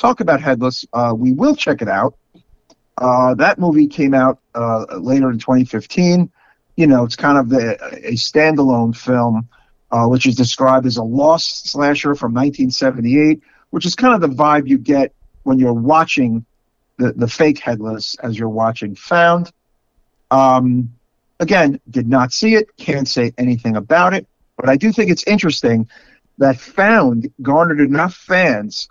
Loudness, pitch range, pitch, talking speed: -15 LUFS, 120-155 Hz, 130 Hz, 160 wpm